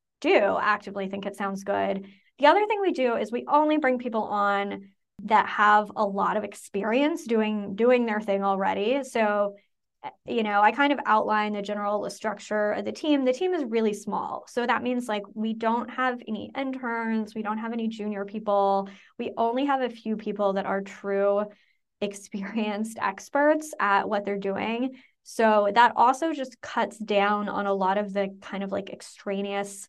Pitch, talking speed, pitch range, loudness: 210 Hz, 185 wpm, 200-240 Hz, -26 LUFS